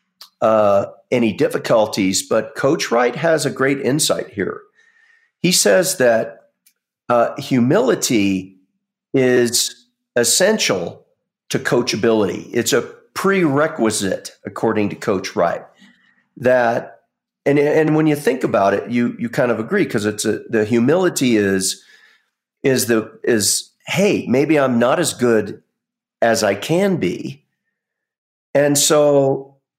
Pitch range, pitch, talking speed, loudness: 115-160 Hz, 135 Hz, 125 wpm, -17 LUFS